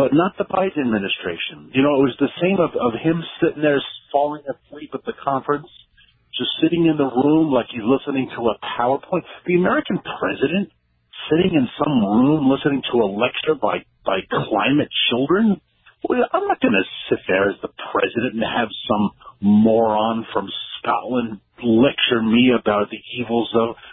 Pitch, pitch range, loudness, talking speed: 135 Hz, 115-165 Hz, -20 LUFS, 170 wpm